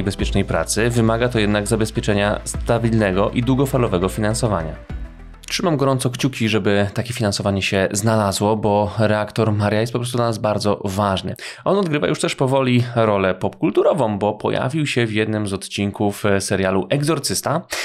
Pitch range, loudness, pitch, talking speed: 100-120 Hz, -19 LUFS, 110 Hz, 150 wpm